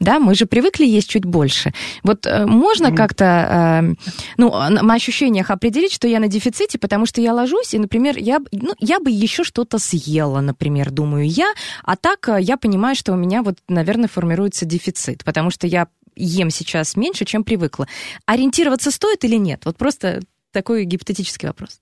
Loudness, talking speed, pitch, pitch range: -17 LUFS, 170 wpm, 210 Hz, 175-240 Hz